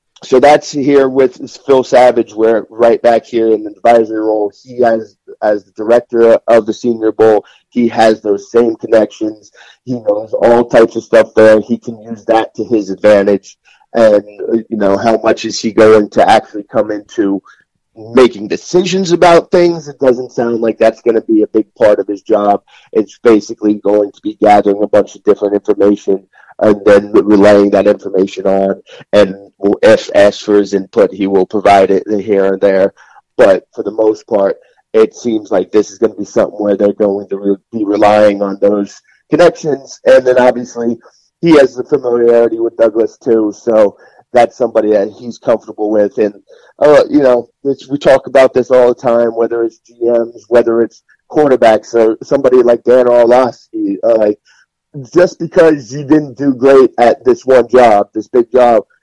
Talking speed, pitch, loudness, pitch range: 185 wpm, 115 Hz, -11 LUFS, 105-130 Hz